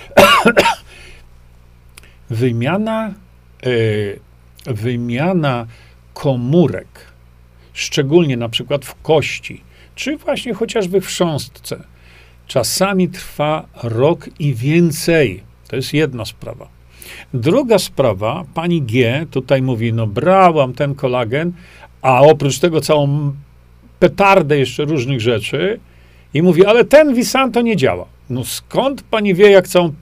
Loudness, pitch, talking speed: -15 LUFS, 135 Hz, 110 wpm